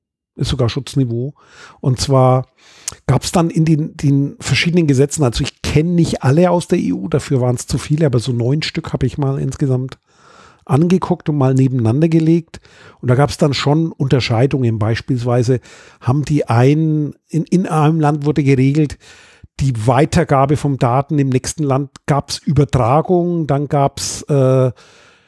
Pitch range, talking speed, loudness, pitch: 130-155 Hz, 165 wpm, -16 LUFS, 140 Hz